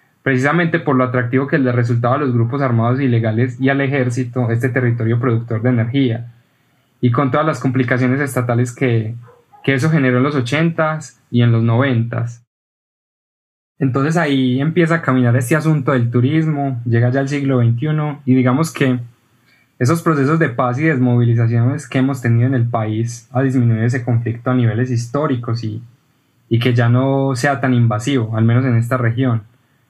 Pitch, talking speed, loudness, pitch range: 125 Hz, 175 wpm, -16 LUFS, 120-135 Hz